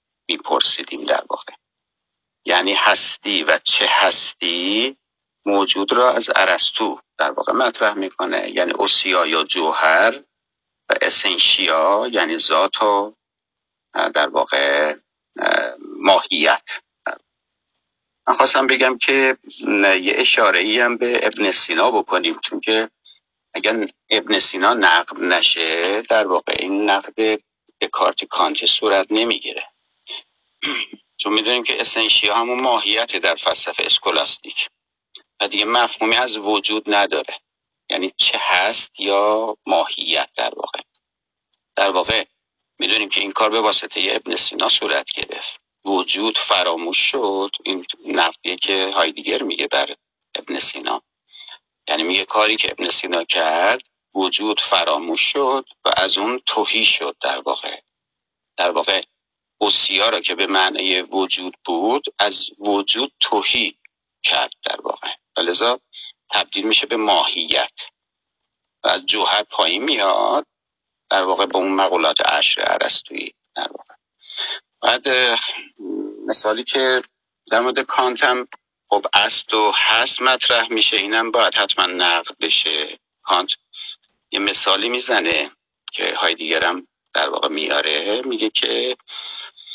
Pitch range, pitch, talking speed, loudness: 100-135 Hz, 110 Hz, 120 wpm, -17 LUFS